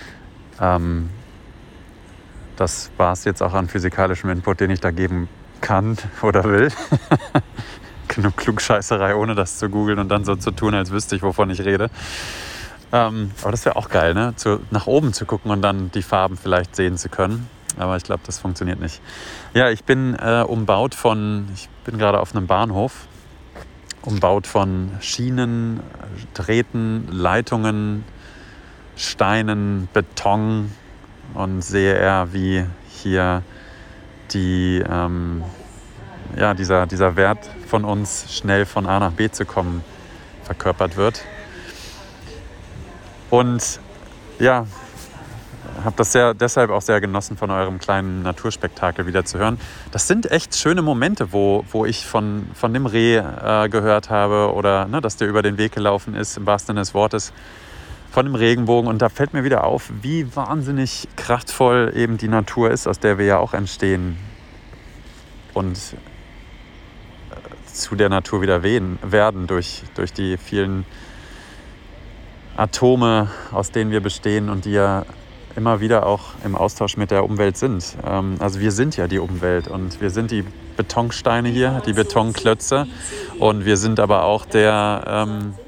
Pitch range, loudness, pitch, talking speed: 95-110 Hz, -19 LUFS, 100 Hz, 150 wpm